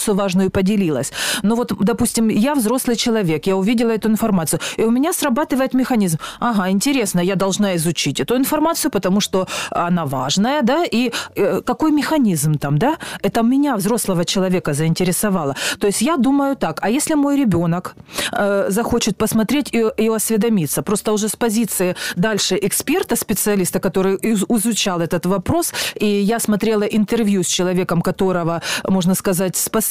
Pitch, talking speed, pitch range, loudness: 210 Hz, 155 wpm, 185-235 Hz, -18 LUFS